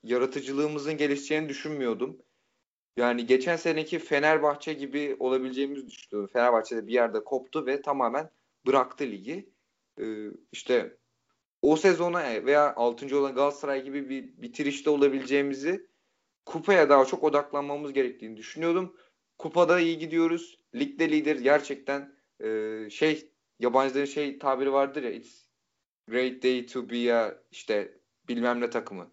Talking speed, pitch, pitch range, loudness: 125 wpm, 140 Hz, 130-155 Hz, -27 LUFS